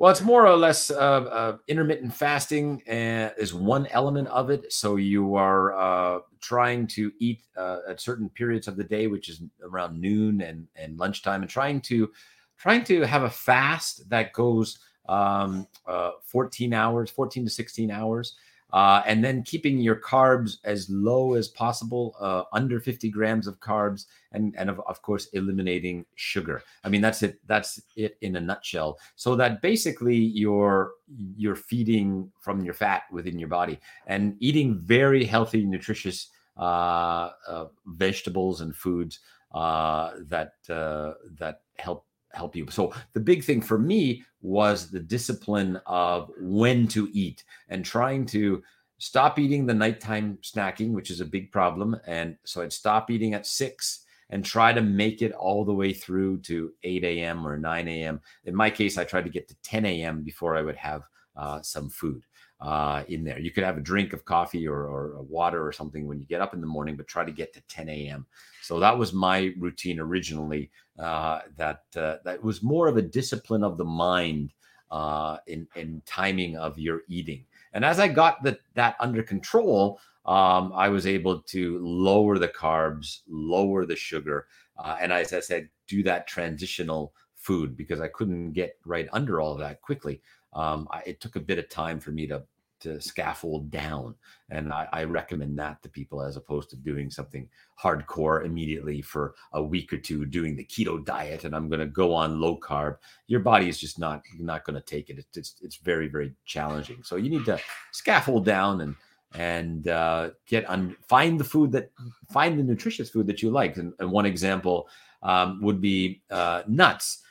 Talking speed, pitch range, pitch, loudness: 185 wpm, 80-115 Hz, 95 Hz, -26 LUFS